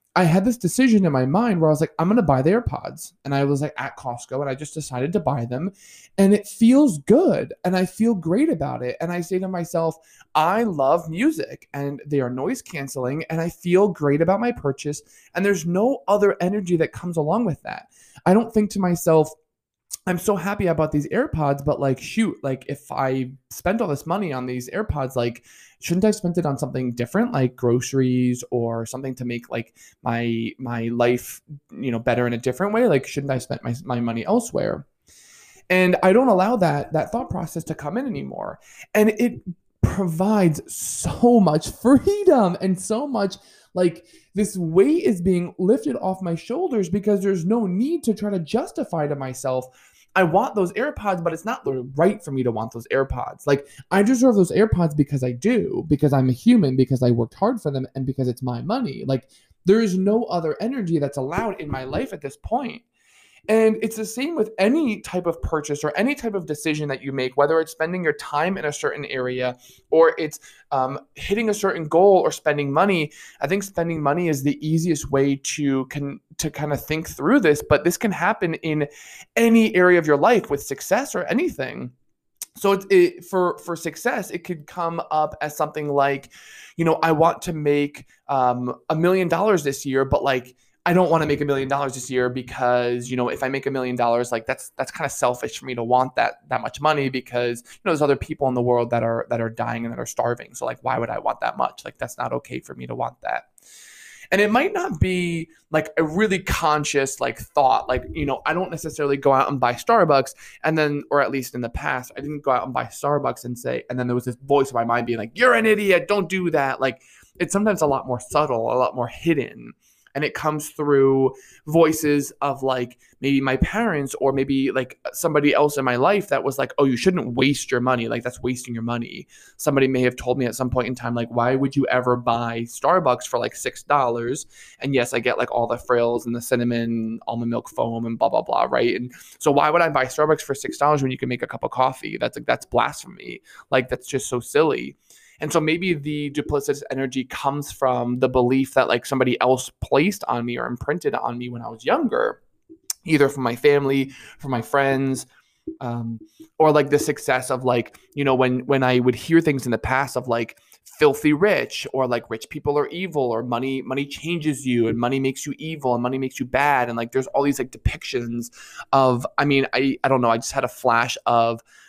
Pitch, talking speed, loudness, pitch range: 145 Hz, 225 wpm, -22 LUFS, 125-180 Hz